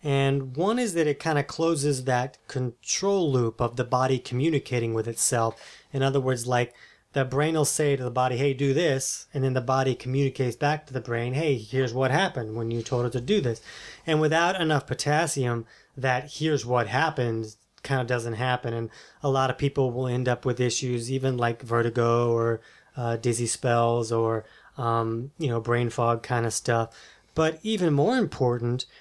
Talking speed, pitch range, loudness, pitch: 190 wpm, 120-145 Hz, -26 LUFS, 130 Hz